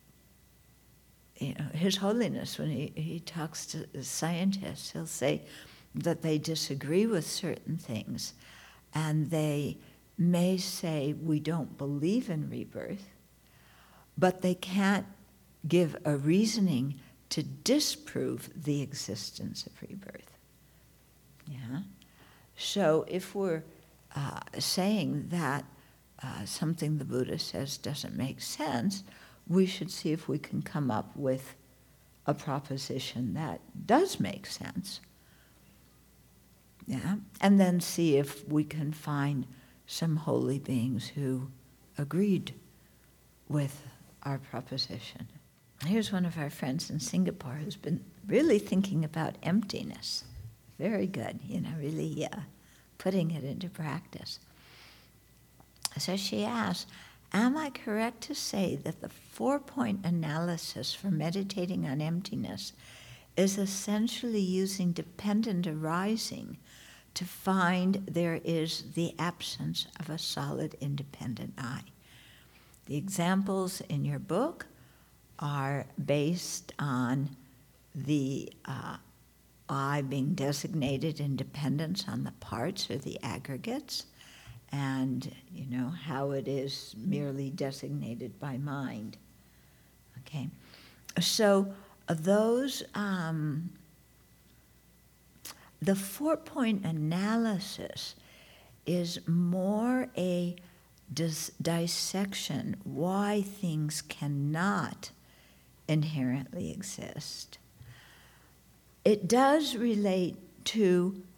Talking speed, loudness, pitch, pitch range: 105 wpm, -32 LUFS, 160 Hz, 140-190 Hz